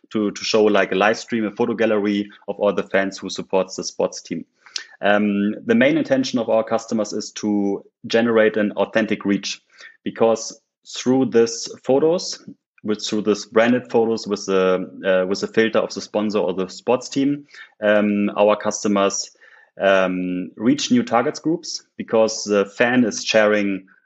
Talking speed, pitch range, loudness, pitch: 165 wpm, 100-115 Hz, -20 LUFS, 105 Hz